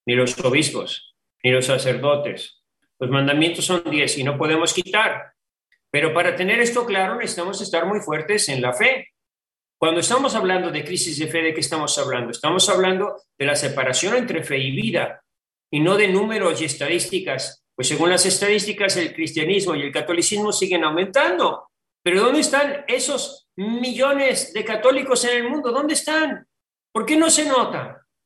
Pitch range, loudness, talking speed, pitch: 155-235 Hz, -20 LUFS, 170 wpm, 185 Hz